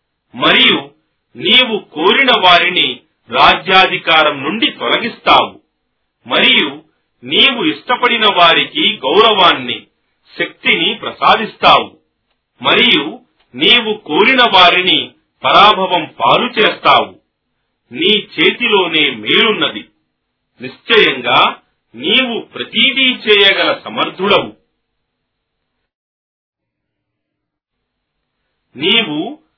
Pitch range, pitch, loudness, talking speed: 175-240 Hz, 200 Hz, -10 LUFS, 60 wpm